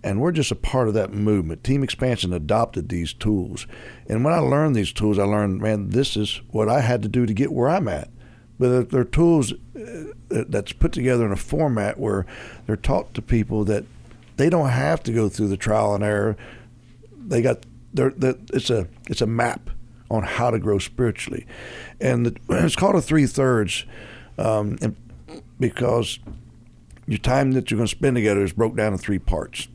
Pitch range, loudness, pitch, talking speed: 105-130 Hz, -22 LUFS, 115 Hz, 195 wpm